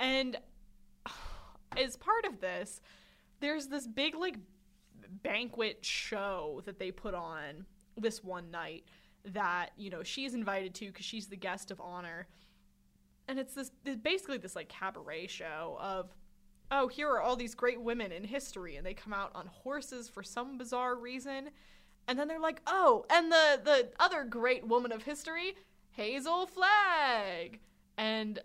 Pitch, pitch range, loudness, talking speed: 235 Hz, 195-275 Hz, -34 LUFS, 160 wpm